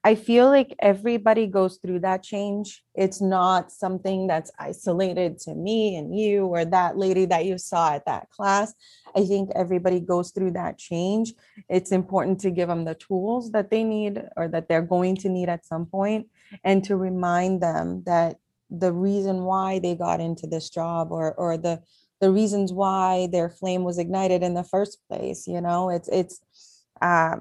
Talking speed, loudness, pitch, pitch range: 185 wpm, -24 LUFS, 185 Hz, 175-200 Hz